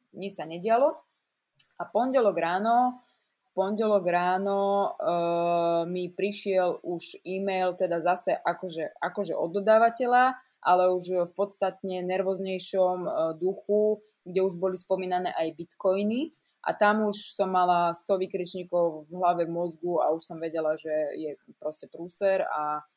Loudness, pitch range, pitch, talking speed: -27 LUFS, 170-200 Hz, 185 Hz, 135 wpm